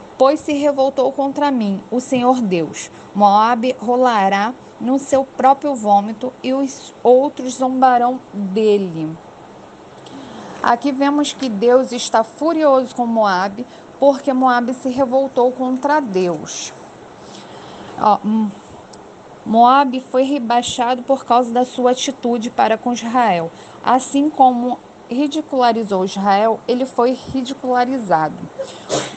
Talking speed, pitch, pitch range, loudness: 105 wpm, 250 Hz, 225-270 Hz, -16 LUFS